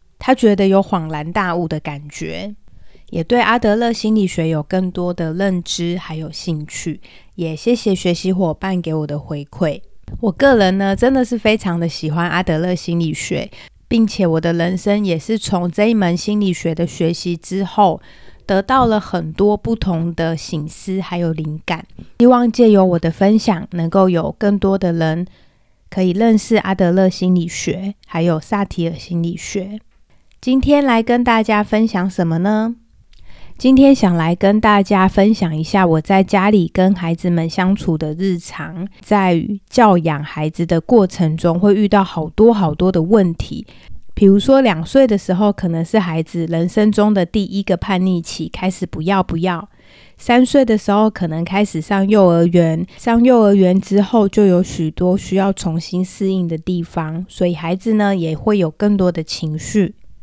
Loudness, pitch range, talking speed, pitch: -16 LUFS, 170-210 Hz, 255 characters per minute, 185 Hz